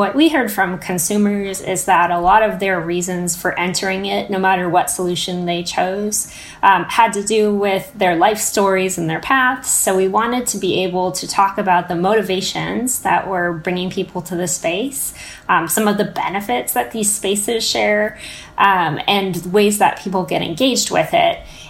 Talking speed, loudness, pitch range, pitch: 190 wpm, -17 LUFS, 180-215 Hz, 195 Hz